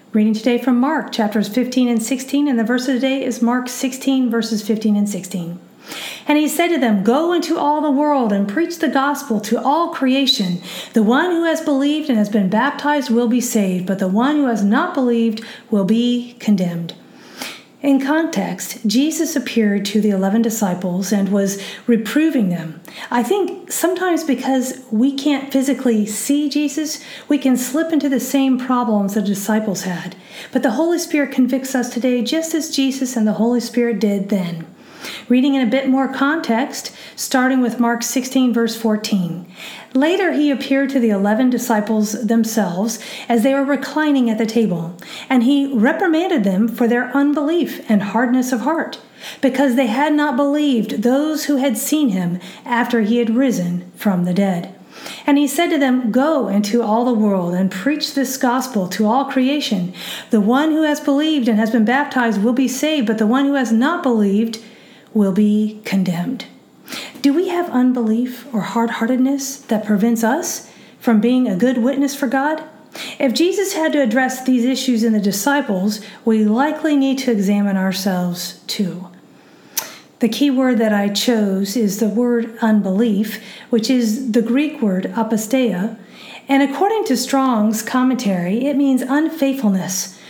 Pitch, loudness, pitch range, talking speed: 245 Hz, -17 LUFS, 215-275 Hz, 170 wpm